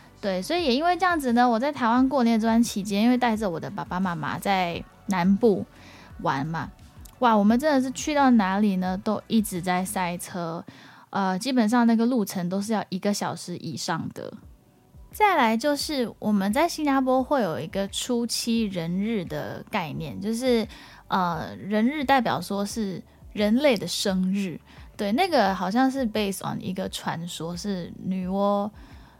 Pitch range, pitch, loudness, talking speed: 190-245 Hz, 210 Hz, -25 LUFS, 260 characters per minute